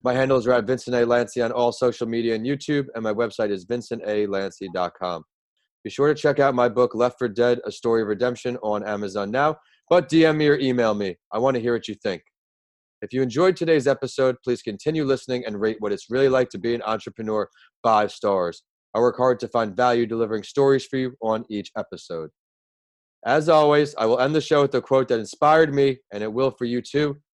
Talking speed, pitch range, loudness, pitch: 220 wpm, 110-135 Hz, -22 LUFS, 125 Hz